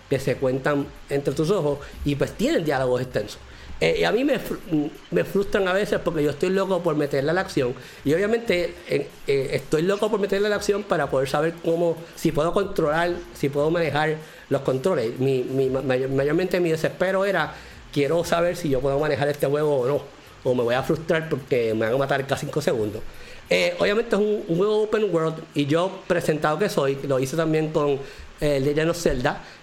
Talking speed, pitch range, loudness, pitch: 205 wpm, 140-185 Hz, -23 LUFS, 160 Hz